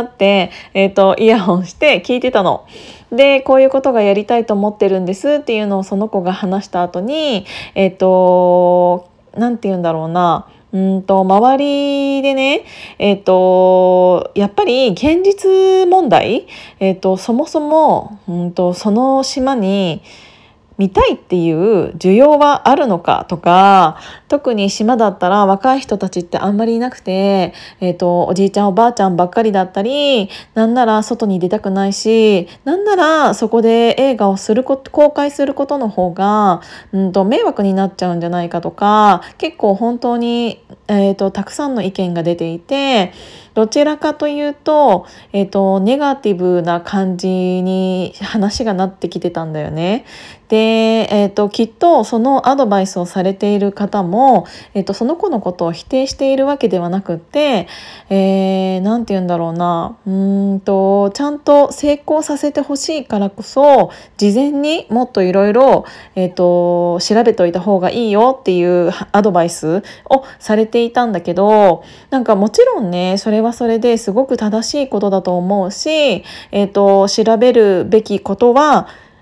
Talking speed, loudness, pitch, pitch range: 325 characters per minute, -13 LUFS, 205 Hz, 190-255 Hz